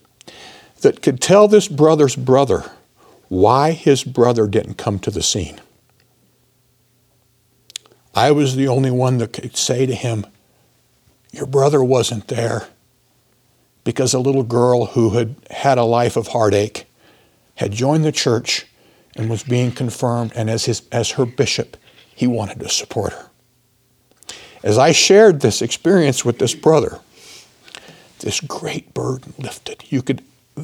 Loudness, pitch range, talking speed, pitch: -17 LUFS, 115-135 Hz, 140 wpm, 125 Hz